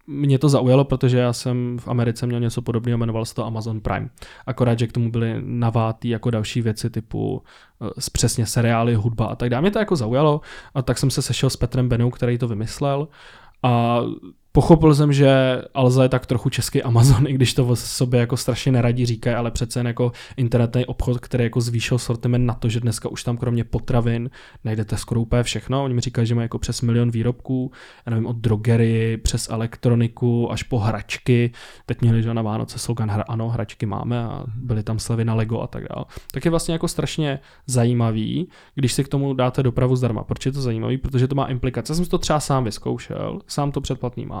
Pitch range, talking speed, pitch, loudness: 115-130 Hz, 210 wpm, 120 Hz, -21 LUFS